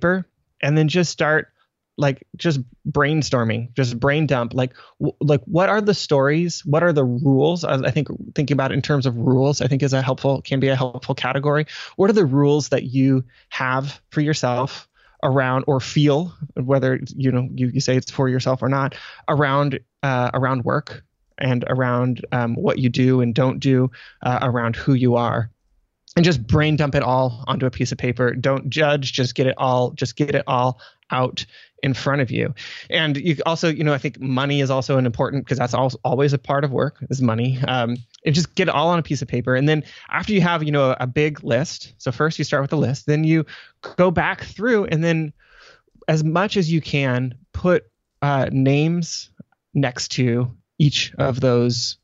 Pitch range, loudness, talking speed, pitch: 130-150 Hz, -20 LUFS, 205 wpm, 135 Hz